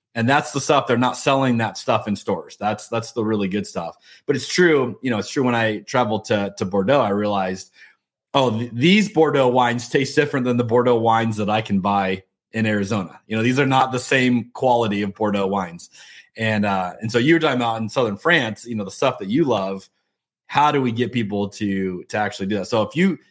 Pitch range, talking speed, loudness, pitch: 100-125 Hz, 235 wpm, -20 LUFS, 115 Hz